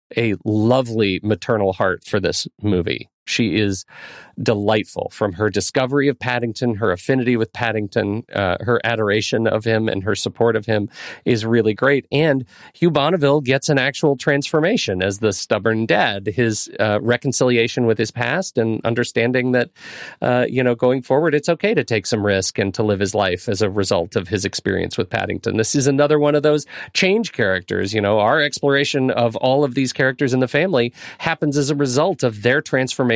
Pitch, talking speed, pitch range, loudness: 120 Hz, 185 wpm, 110-140 Hz, -19 LUFS